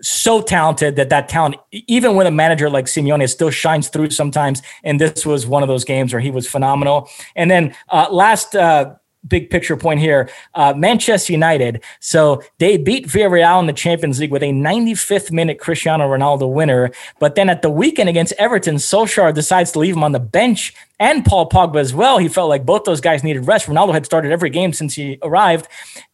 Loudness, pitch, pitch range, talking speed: -14 LUFS, 155 Hz, 145-175 Hz, 205 wpm